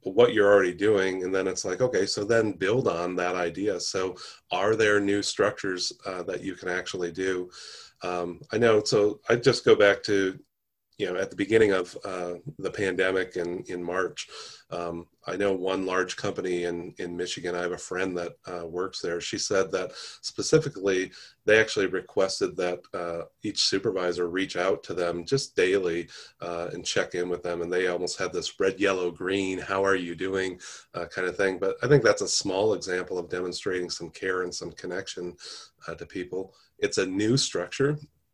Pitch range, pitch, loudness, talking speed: 90-100 Hz, 95 Hz, -27 LUFS, 195 wpm